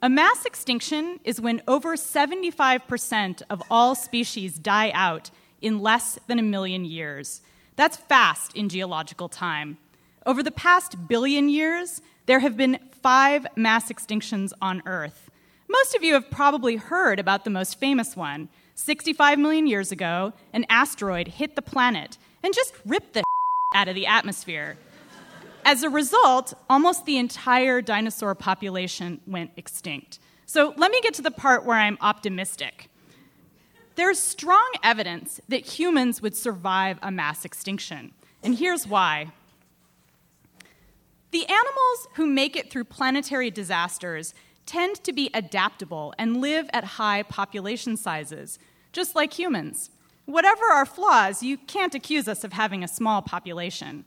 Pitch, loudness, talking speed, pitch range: 235 Hz, -23 LUFS, 145 wpm, 190-295 Hz